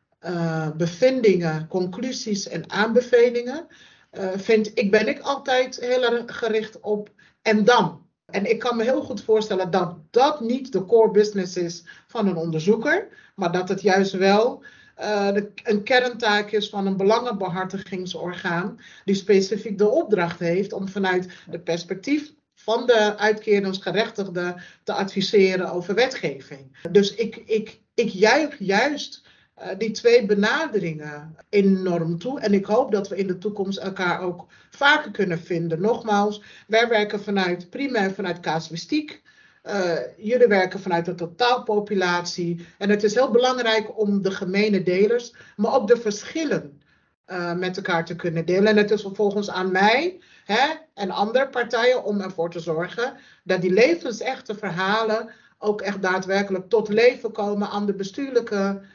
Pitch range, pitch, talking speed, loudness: 185-235 Hz, 205 Hz, 150 wpm, -22 LUFS